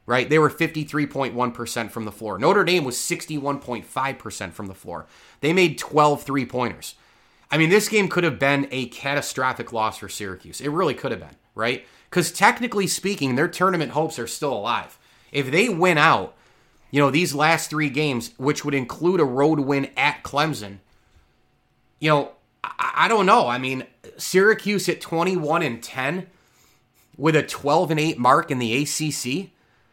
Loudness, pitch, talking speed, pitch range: -22 LUFS, 140 Hz, 170 wpm, 120-160 Hz